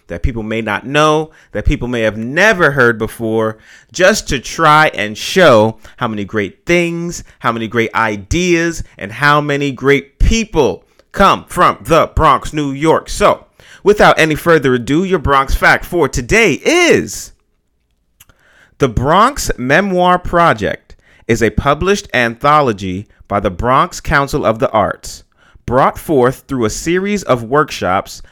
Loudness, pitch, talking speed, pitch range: -13 LUFS, 135 Hz, 145 wpm, 110-165 Hz